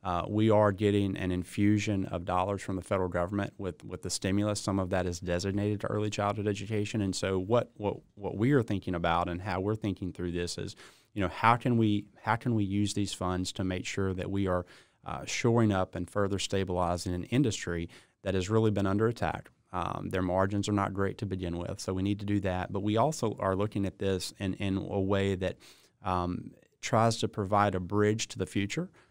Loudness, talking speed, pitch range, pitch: -31 LUFS, 225 wpm, 90-105 Hz, 100 Hz